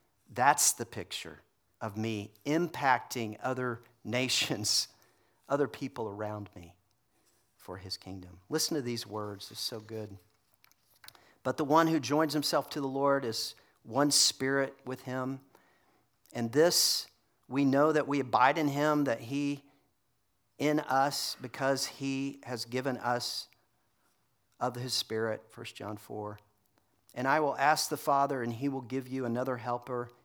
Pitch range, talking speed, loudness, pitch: 110-140 Hz, 145 wpm, -31 LUFS, 125 Hz